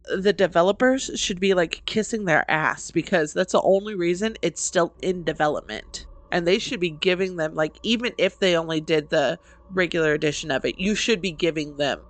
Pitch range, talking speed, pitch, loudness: 160-205 Hz, 195 wpm, 180 Hz, -23 LUFS